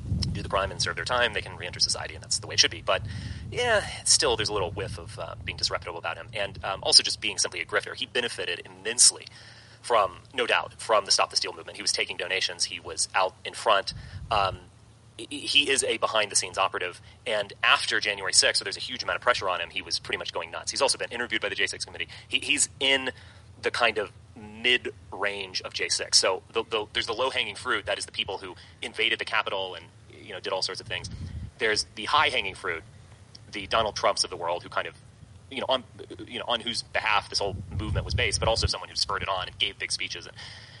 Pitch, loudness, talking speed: 115 Hz, -26 LUFS, 245 wpm